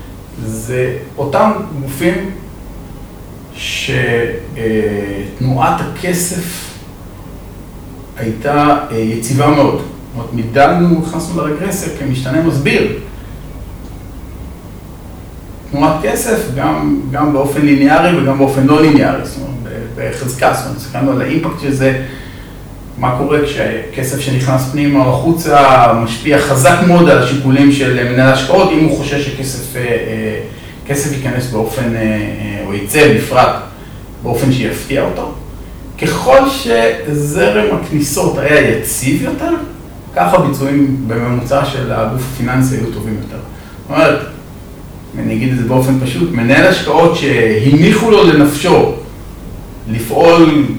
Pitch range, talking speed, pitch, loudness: 110-145 Hz, 110 wpm, 130 Hz, -12 LUFS